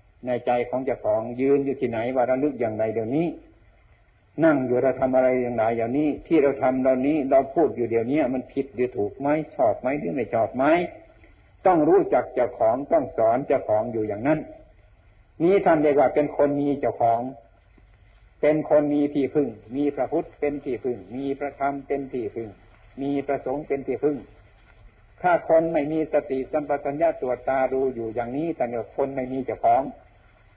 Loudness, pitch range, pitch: -24 LUFS, 110-145 Hz, 130 Hz